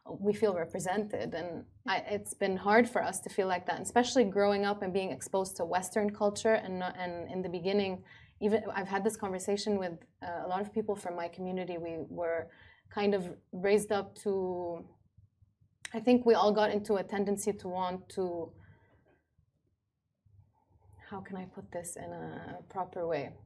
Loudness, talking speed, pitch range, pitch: -33 LUFS, 180 wpm, 170-205 Hz, 190 Hz